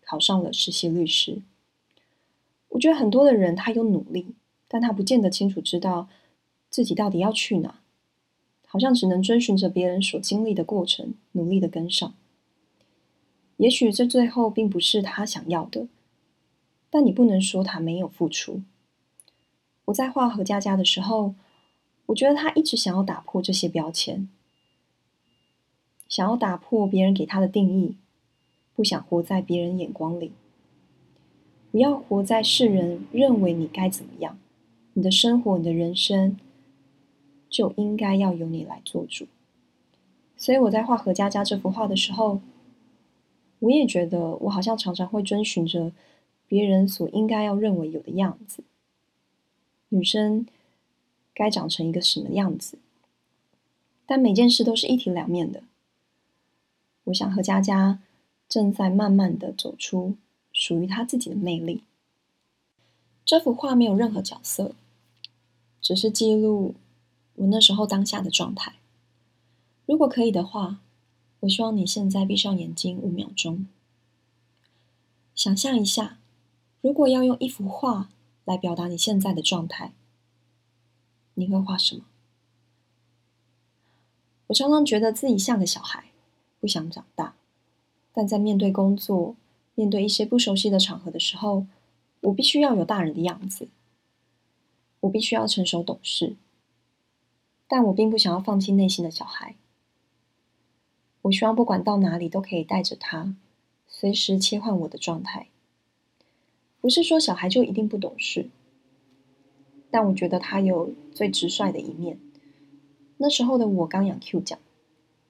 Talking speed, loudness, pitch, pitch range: 215 characters per minute, -23 LUFS, 195 Hz, 170-220 Hz